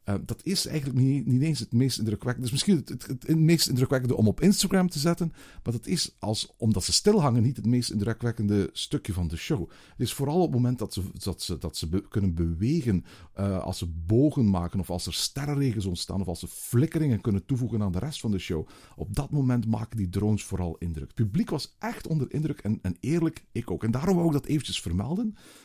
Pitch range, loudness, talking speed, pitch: 95-145 Hz, -27 LUFS, 225 wpm, 115 Hz